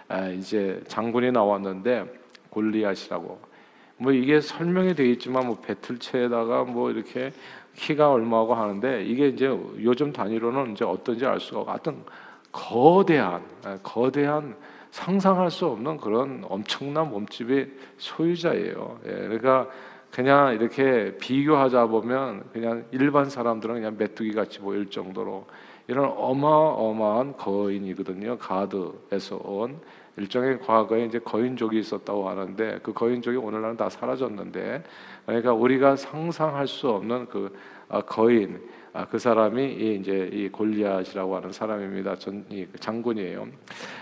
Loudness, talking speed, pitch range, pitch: -25 LUFS, 300 characters per minute, 105-135 Hz, 120 Hz